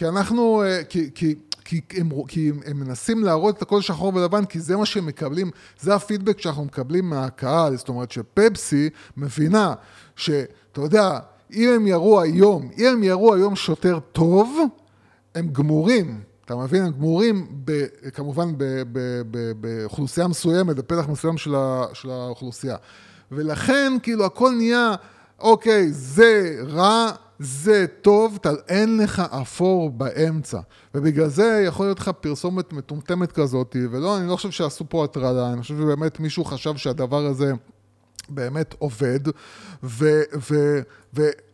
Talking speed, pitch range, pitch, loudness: 125 wpm, 135-195 Hz, 160 Hz, -21 LUFS